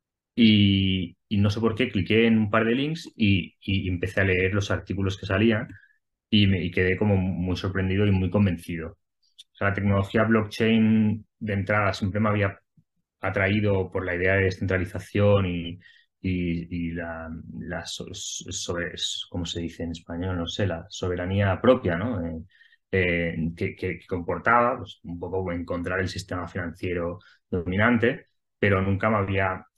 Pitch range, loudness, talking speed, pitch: 90-105 Hz, -25 LUFS, 165 wpm, 95 Hz